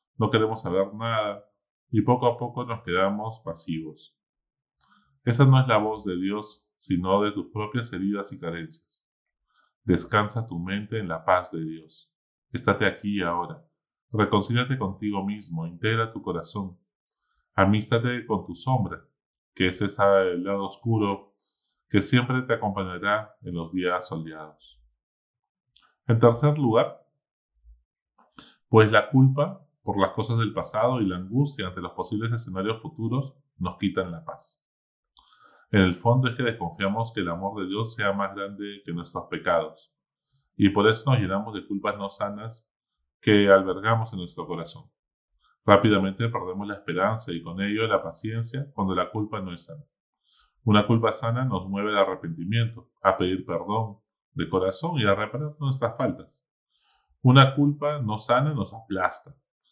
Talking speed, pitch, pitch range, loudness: 155 wpm, 105 Hz, 95-120 Hz, -25 LUFS